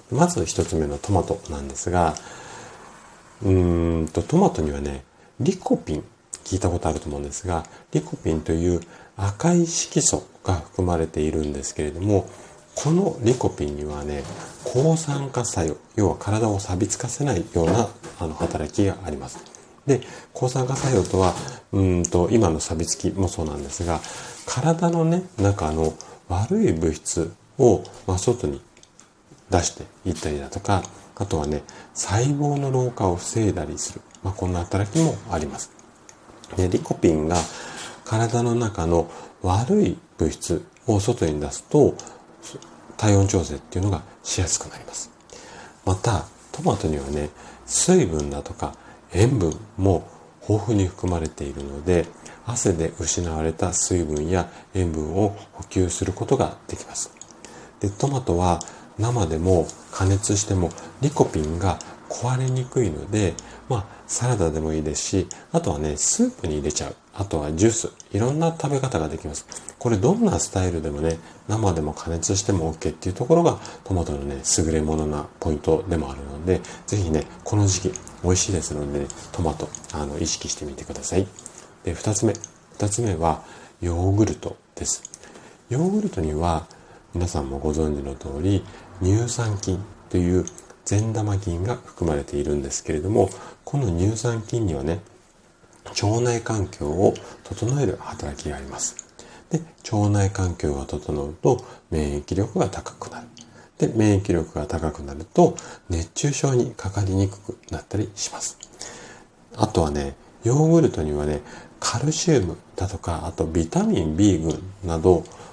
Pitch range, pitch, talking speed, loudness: 80-110 Hz, 90 Hz, 295 characters per minute, -24 LUFS